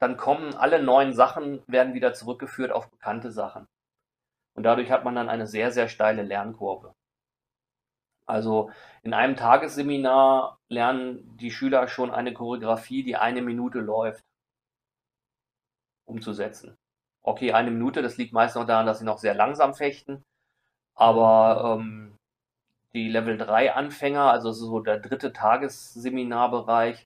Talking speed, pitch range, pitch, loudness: 135 wpm, 115-130 Hz, 120 Hz, -24 LUFS